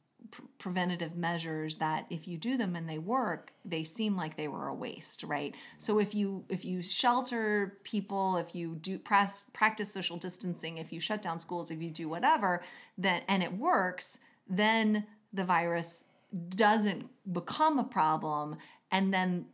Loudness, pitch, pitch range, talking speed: -32 LUFS, 185 Hz, 170-210 Hz, 165 wpm